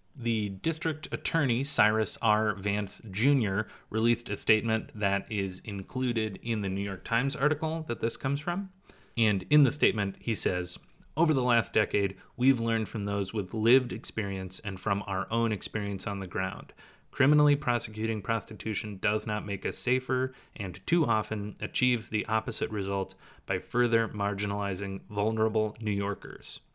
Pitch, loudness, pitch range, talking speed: 110 Hz, -29 LUFS, 100-120 Hz, 155 wpm